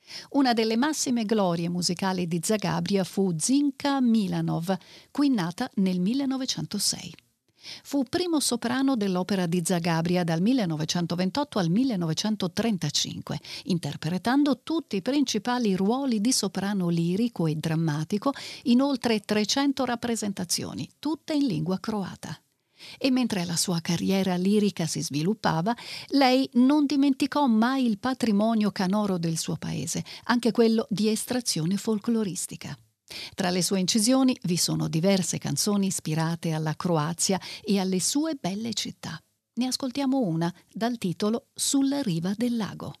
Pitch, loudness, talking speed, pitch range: 205 Hz, -26 LUFS, 125 wpm, 175-245 Hz